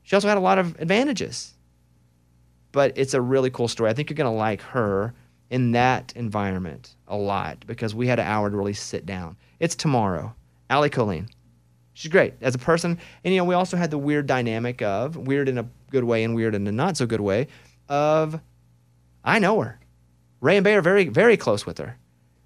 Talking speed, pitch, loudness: 210 wpm, 115 Hz, -23 LUFS